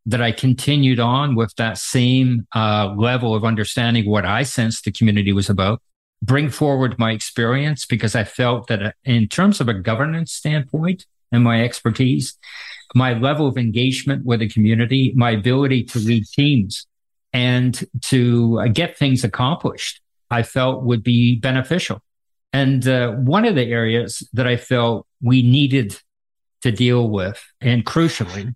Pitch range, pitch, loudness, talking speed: 115-130 Hz, 120 Hz, -18 LUFS, 155 wpm